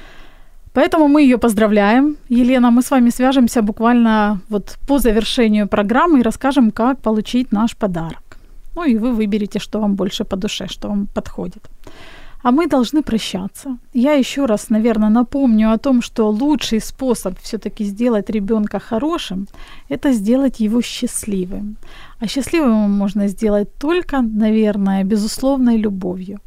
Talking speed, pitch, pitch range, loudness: 140 wpm, 225 Hz, 210-255 Hz, -16 LUFS